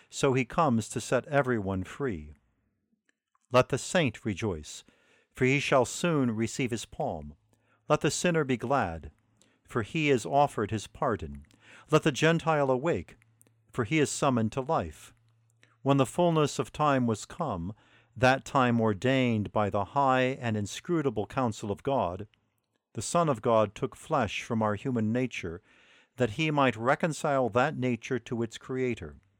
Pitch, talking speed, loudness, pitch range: 125 Hz, 155 wpm, -29 LUFS, 110-140 Hz